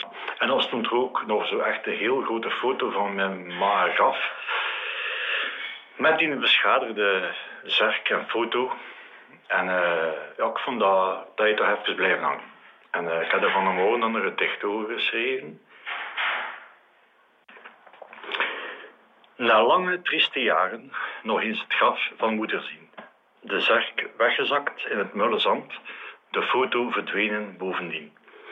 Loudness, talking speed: -24 LUFS, 140 wpm